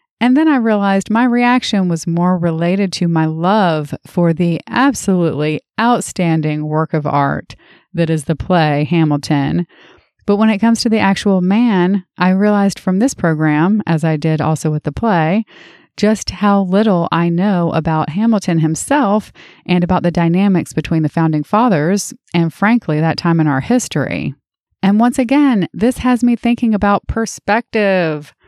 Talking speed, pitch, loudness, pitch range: 160 wpm, 185 Hz, -15 LUFS, 160-215 Hz